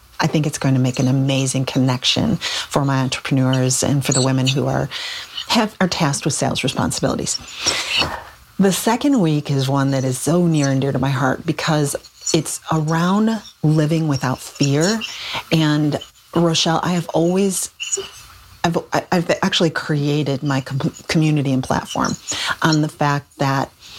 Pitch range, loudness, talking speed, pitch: 135-165 Hz, -19 LUFS, 155 wpm, 150 Hz